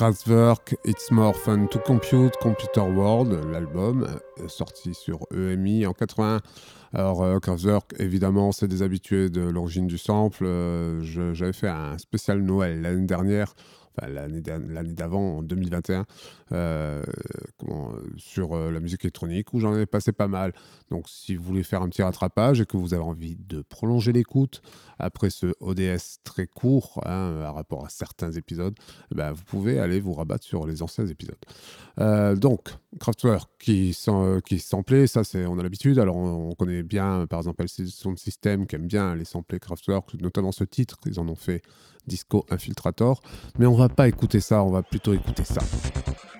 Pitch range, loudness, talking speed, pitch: 85-105 Hz, -25 LUFS, 175 wpm, 95 Hz